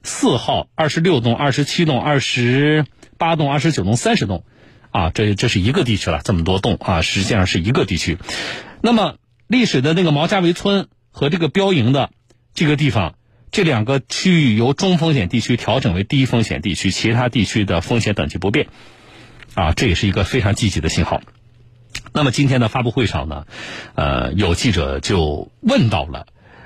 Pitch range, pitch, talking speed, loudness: 100-150 Hz, 120 Hz, 280 characters per minute, -17 LUFS